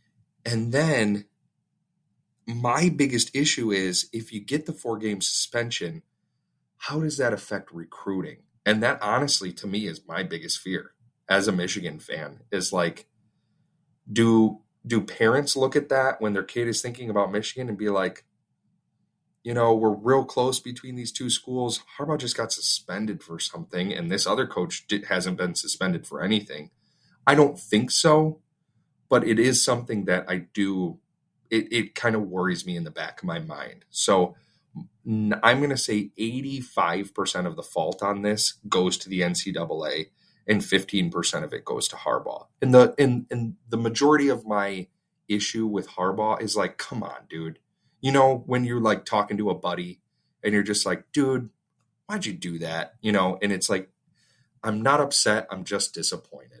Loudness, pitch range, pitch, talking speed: -25 LUFS, 100-130 Hz, 115 Hz, 175 wpm